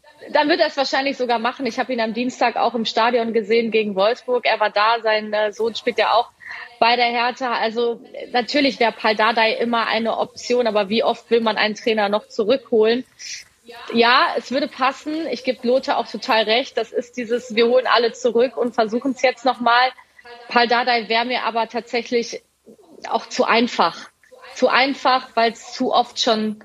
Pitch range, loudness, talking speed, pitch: 225-255 Hz, -19 LUFS, 190 wpm, 240 Hz